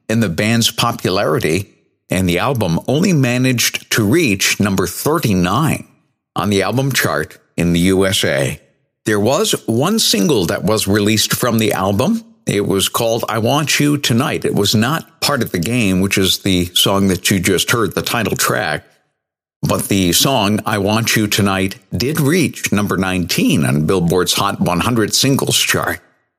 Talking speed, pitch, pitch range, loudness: 165 wpm, 110 Hz, 95-125 Hz, -15 LUFS